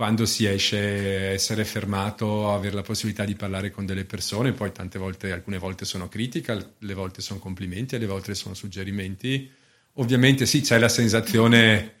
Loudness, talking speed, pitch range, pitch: -24 LUFS, 165 wpm, 95-115 Hz, 105 Hz